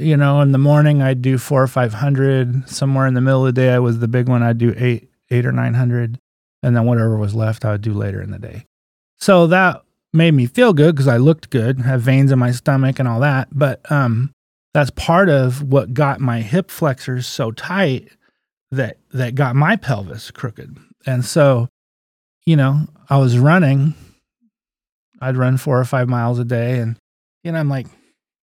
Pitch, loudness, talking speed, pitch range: 130 Hz, -16 LUFS, 205 wpm, 120-140 Hz